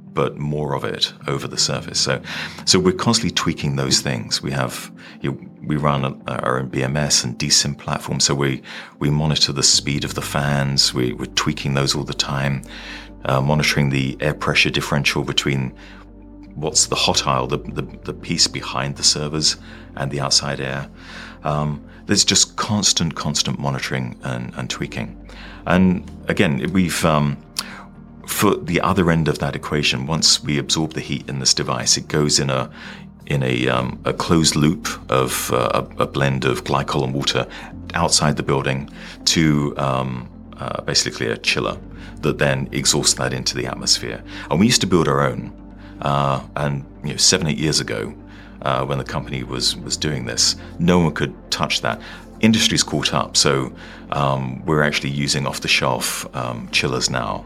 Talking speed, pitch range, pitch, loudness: 175 wpm, 70-75 Hz, 70 Hz, -19 LUFS